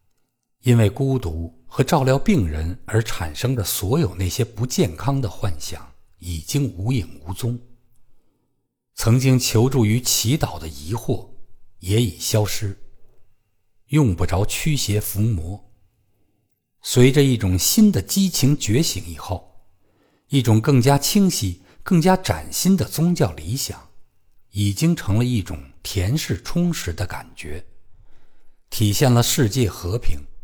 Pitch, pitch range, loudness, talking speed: 110 Hz, 95-130 Hz, -20 LUFS, 190 characters per minute